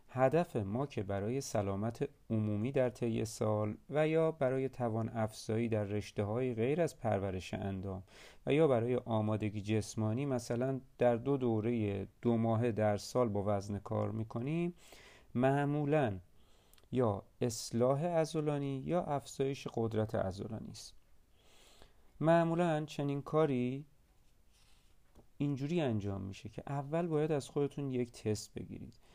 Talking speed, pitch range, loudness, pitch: 125 wpm, 105-140 Hz, -35 LUFS, 120 Hz